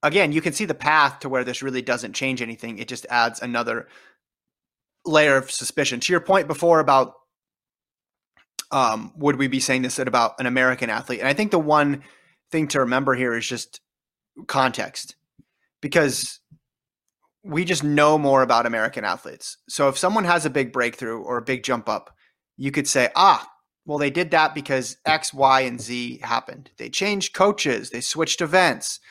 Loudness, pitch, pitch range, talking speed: -21 LUFS, 135 Hz, 125-155 Hz, 180 wpm